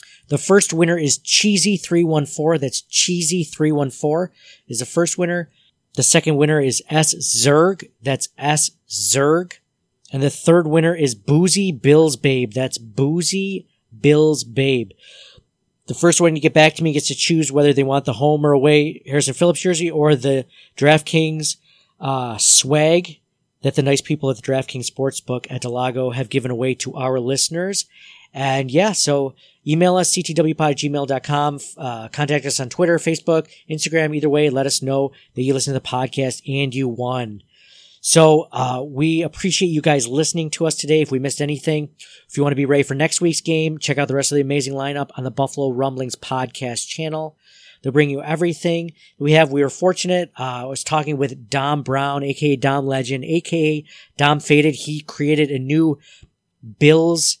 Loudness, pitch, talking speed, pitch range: -18 LUFS, 150 Hz, 175 wpm, 135-160 Hz